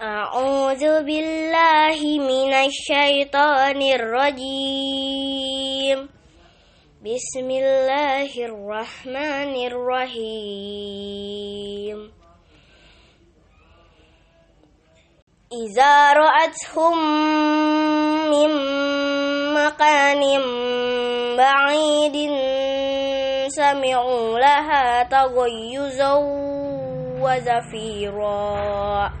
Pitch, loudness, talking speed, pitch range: 270 Hz, -19 LUFS, 35 wpm, 225-285 Hz